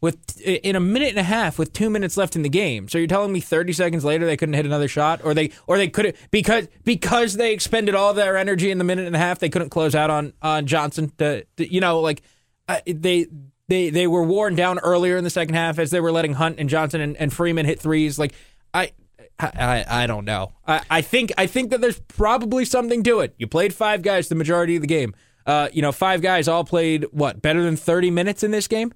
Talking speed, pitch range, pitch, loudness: 250 wpm, 155-195 Hz, 170 Hz, -20 LUFS